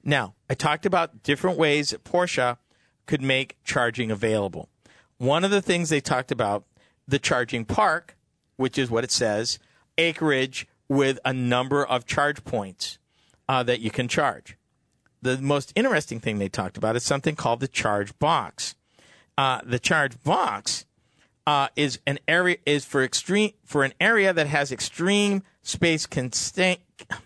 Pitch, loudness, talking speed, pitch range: 135 Hz, -24 LUFS, 155 wpm, 120-150 Hz